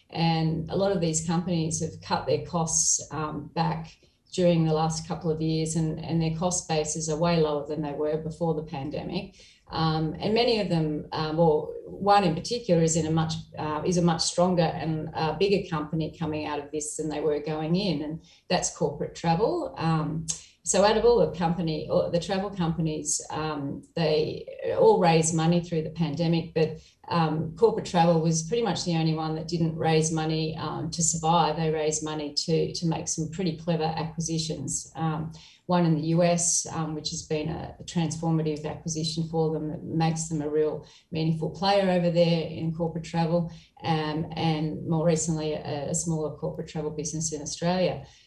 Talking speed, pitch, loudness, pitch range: 185 wpm, 160 Hz, -27 LUFS, 155-170 Hz